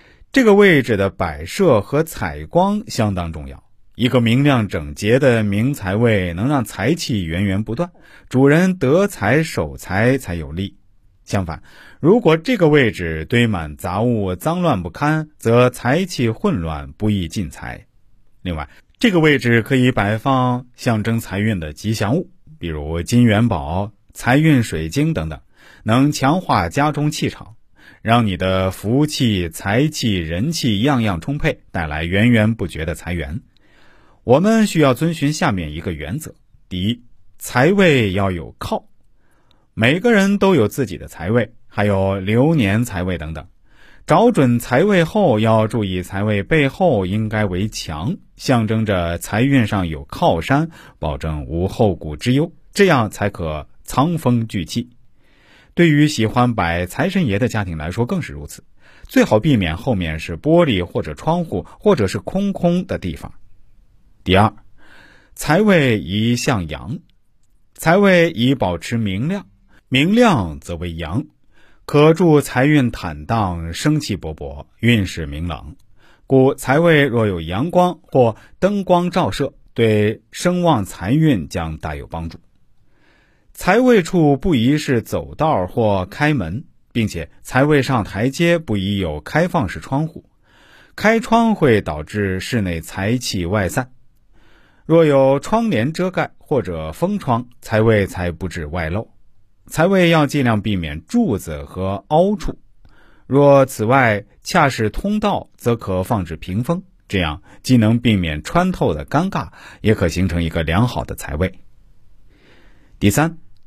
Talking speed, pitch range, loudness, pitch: 210 characters per minute, 95-145 Hz, -17 LUFS, 115 Hz